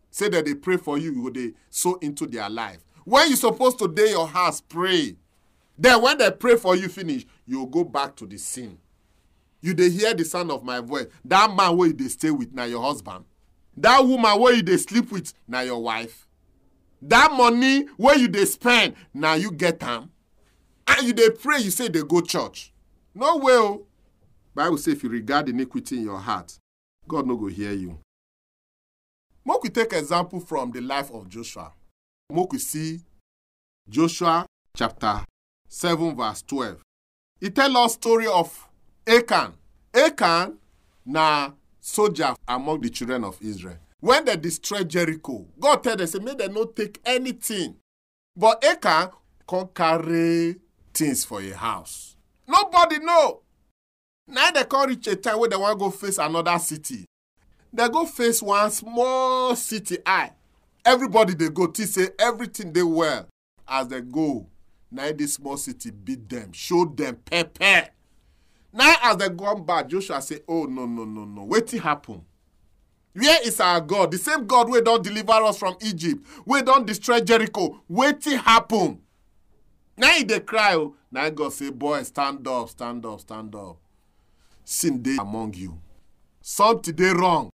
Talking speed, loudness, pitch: 175 wpm, -21 LUFS, 170 Hz